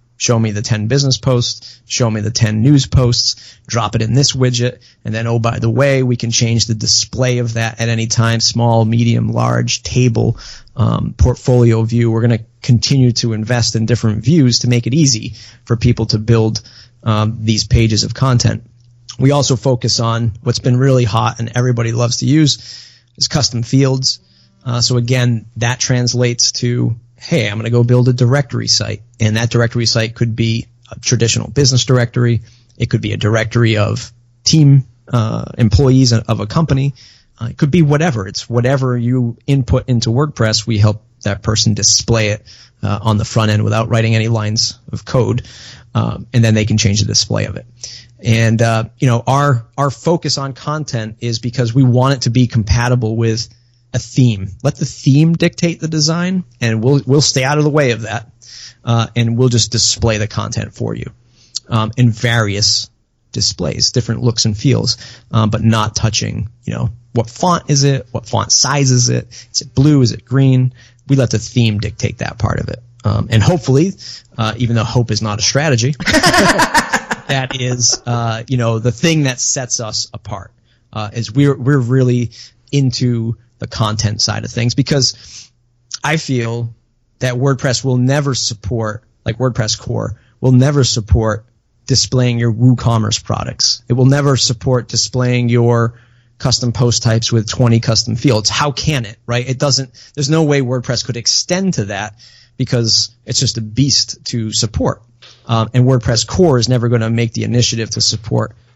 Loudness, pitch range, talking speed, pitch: -14 LUFS, 115-130 Hz, 185 wpm, 120 Hz